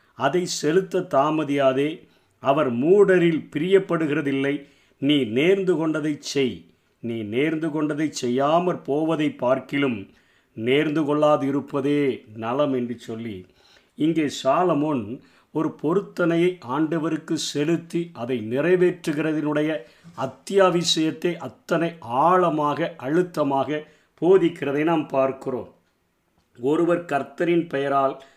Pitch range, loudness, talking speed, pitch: 135-170 Hz, -23 LUFS, 80 wpm, 150 Hz